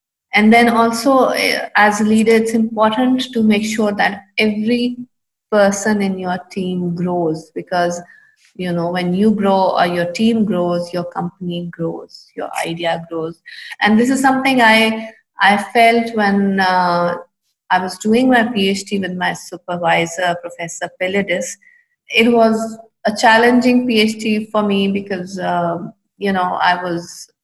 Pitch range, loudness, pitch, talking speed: 180-225 Hz, -15 LUFS, 200 Hz, 145 wpm